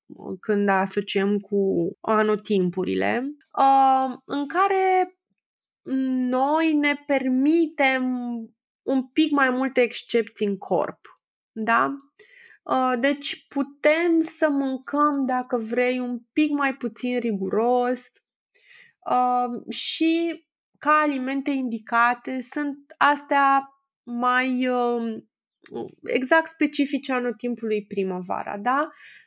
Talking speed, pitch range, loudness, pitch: 80 wpm, 240-295 Hz, -23 LUFS, 260 Hz